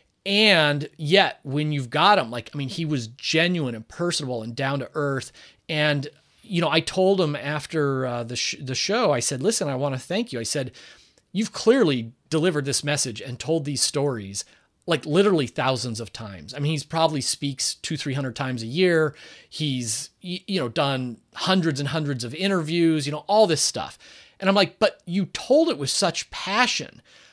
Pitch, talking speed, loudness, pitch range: 150 Hz, 195 wpm, -23 LUFS, 130-175 Hz